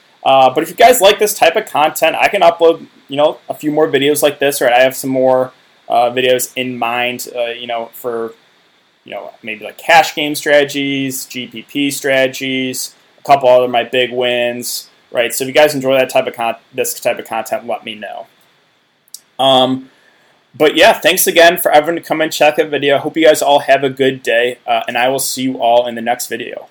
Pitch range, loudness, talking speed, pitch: 125-150 Hz, -13 LUFS, 220 wpm, 135 Hz